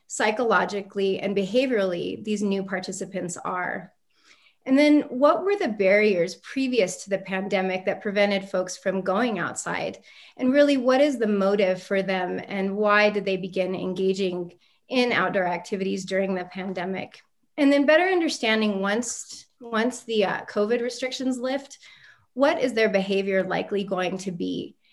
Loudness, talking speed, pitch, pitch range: -24 LUFS, 145 wpm, 200 Hz, 190-245 Hz